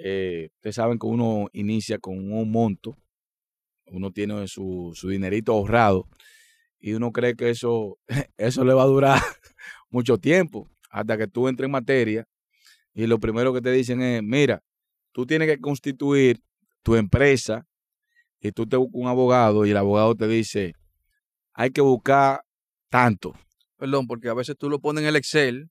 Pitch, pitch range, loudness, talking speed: 120 Hz, 105-135 Hz, -22 LUFS, 170 wpm